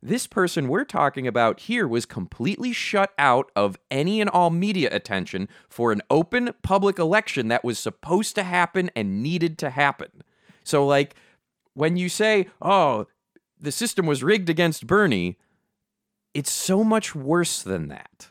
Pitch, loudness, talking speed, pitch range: 170 Hz, -23 LUFS, 155 wpm, 135-200 Hz